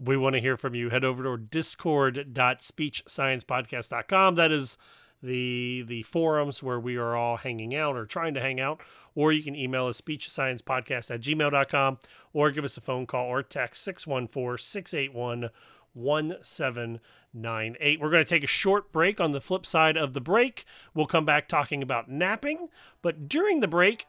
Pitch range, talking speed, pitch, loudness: 125-160 Hz, 165 wpm, 140 Hz, -27 LUFS